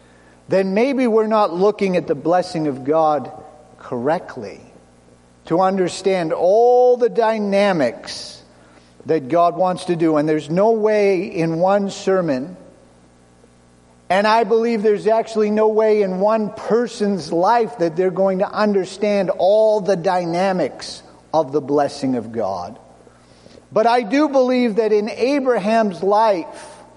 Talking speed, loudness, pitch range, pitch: 135 wpm, -18 LUFS, 155-220 Hz, 190 Hz